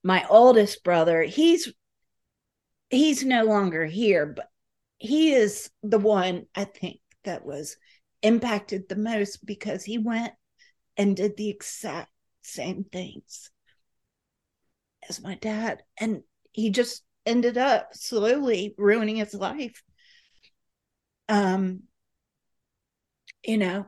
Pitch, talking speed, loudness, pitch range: 215 Hz, 110 wpm, -24 LUFS, 195-235 Hz